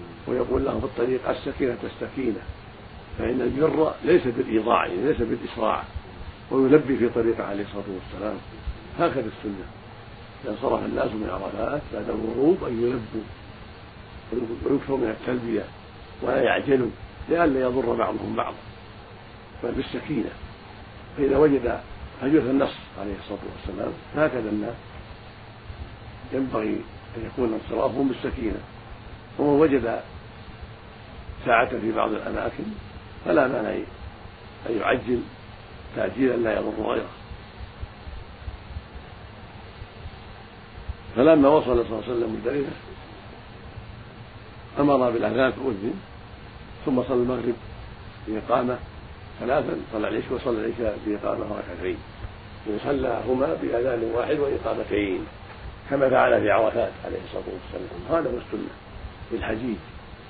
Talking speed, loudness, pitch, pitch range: 105 wpm, -25 LUFS, 110 Hz, 105-120 Hz